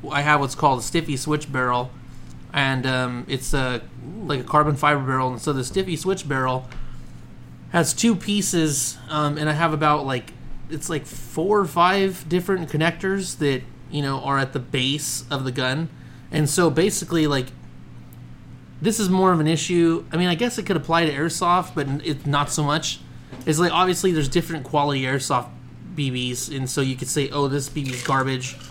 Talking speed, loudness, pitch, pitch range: 190 wpm, -22 LUFS, 145 Hz, 130-165 Hz